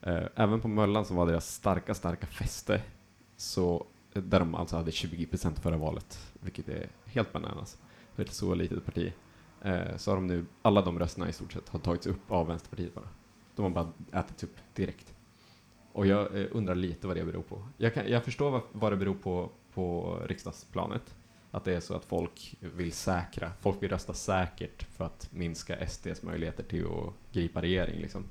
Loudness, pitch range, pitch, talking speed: -33 LUFS, 85-105 Hz, 95 Hz, 190 wpm